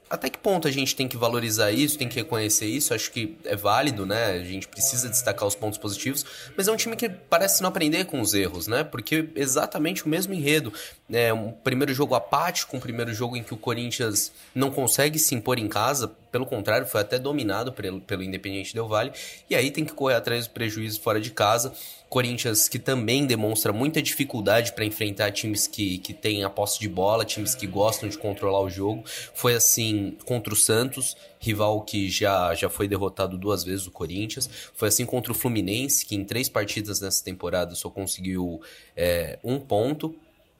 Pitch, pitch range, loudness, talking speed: 115 Hz, 100-135 Hz, -25 LUFS, 200 wpm